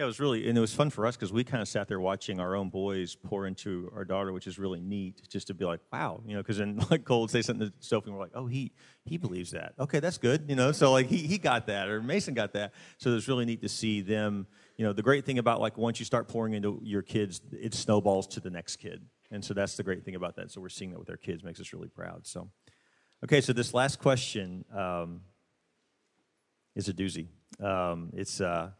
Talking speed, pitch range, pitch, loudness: 265 wpm, 95-120 Hz, 105 Hz, -31 LUFS